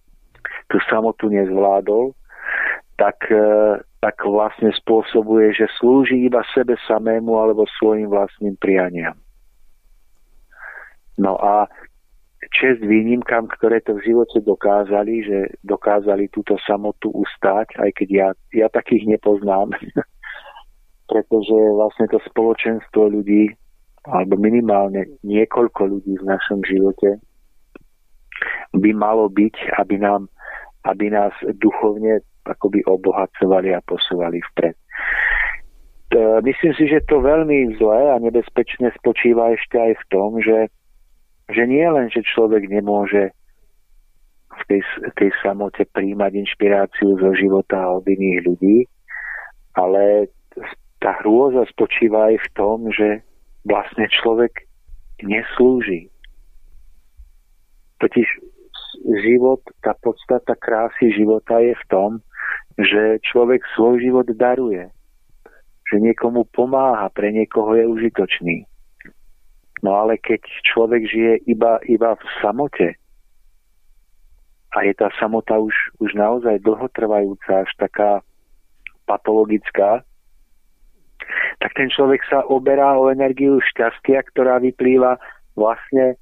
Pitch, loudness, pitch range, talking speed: 105 Hz, -17 LUFS, 100-115 Hz, 110 wpm